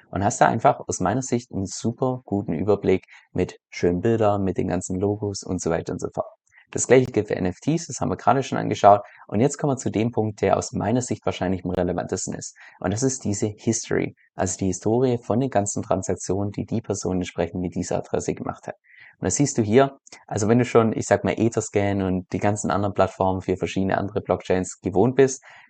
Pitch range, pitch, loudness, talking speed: 95-120 Hz, 100 Hz, -23 LUFS, 220 wpm